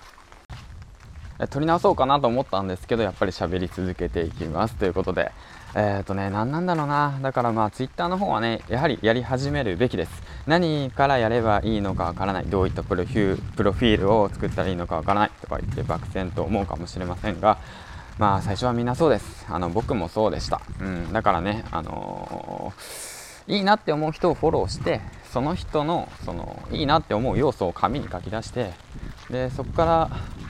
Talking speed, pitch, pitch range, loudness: 400 characters per minute, 105 Hz, 95-130 Hz, -24 LUFS